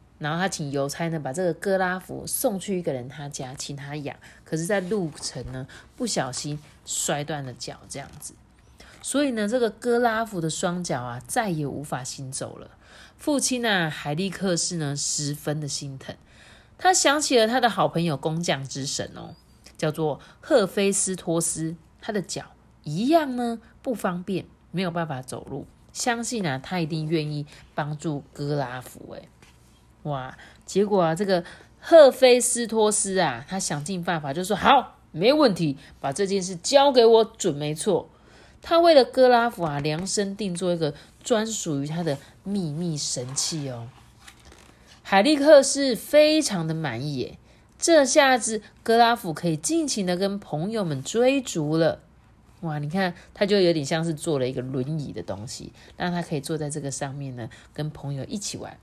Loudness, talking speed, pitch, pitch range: -24 LUFS, 245 characters per minute, 170 Hz, 145-215 Hz